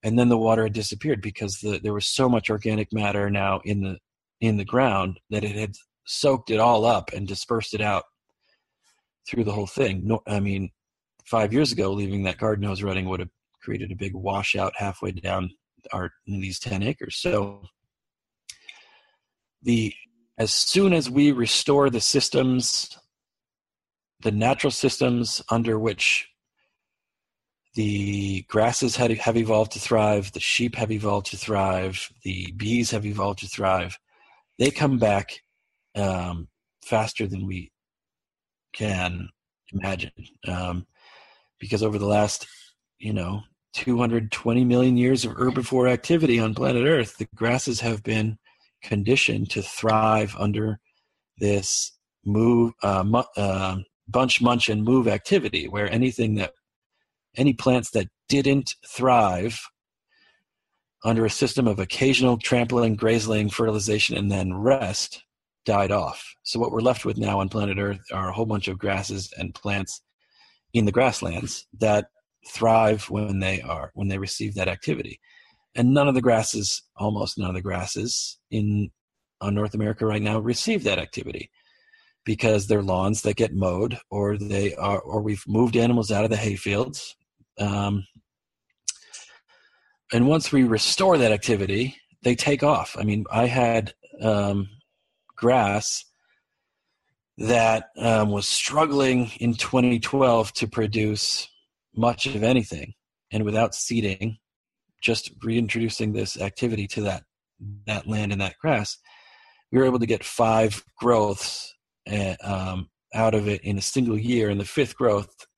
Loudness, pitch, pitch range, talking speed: -24 LUFS, 110 Hz, 100-120 Hz, 145 wpm